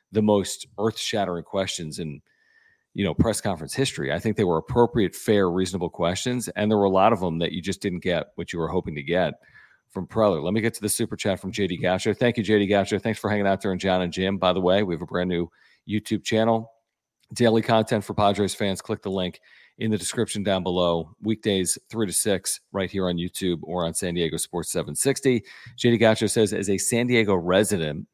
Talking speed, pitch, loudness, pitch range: 225 wpm, 100 Hz, -24 LUFS, 90-115 Hz